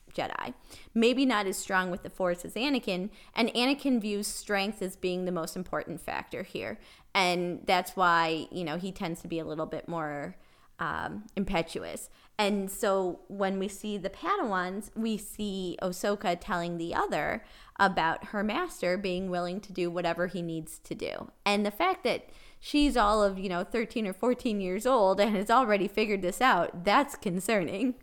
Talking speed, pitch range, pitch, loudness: 180 wpm, 180-210 Hz, 195 Hz, -30 LUFS